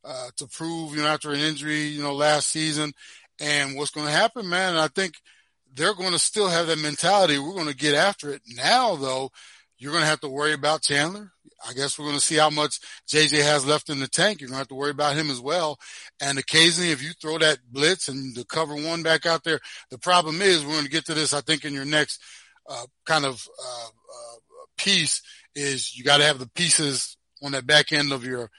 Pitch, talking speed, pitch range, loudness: 150 Hz, 240 wpm, 140-160 Hz, -22 LUFS